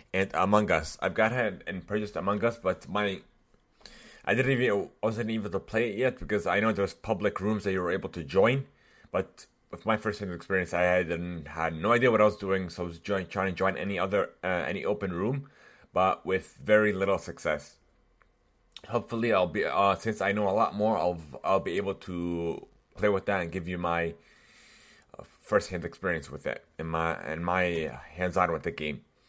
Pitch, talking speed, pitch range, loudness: 95 Hz, 205 wpm, 85-105 Hz, -29 LUFS